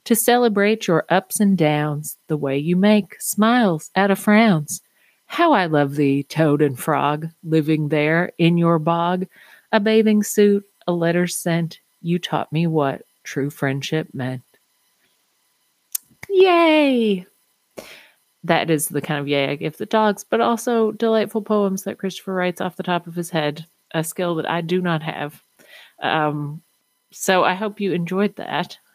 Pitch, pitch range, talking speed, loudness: 175 Hz, 155-205 Hz, 160 wpm, -20 LUFS